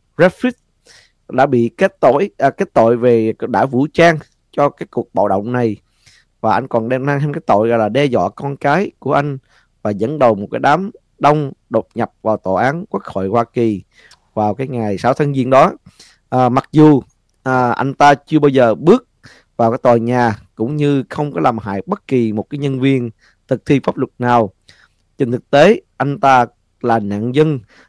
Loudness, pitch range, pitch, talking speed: -15 LUFS, 110-145 Hz, 125 Hz, 205 wpm